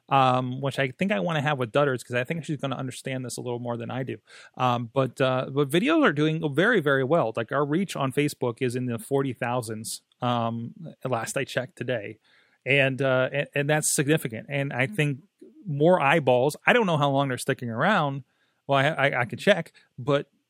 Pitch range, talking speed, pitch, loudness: 125-150 Hz, 220 wpm, 135 Hz, -25 LUFS